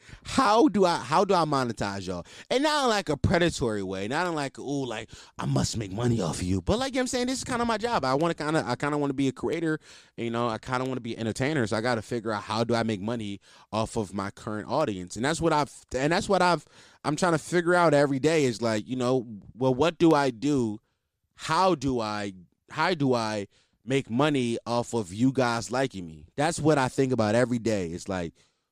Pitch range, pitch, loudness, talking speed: 110-155 Hz, 130 Hz, -27 LUFS, 265 wpm